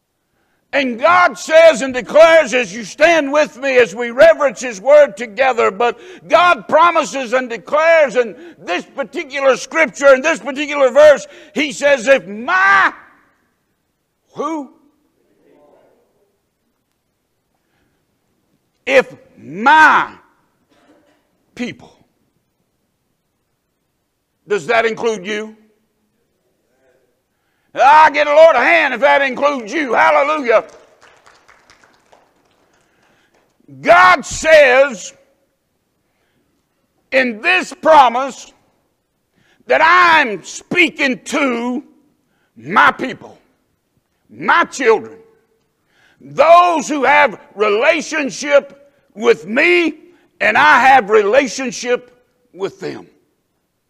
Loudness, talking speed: -12 LUFS, 85 wpm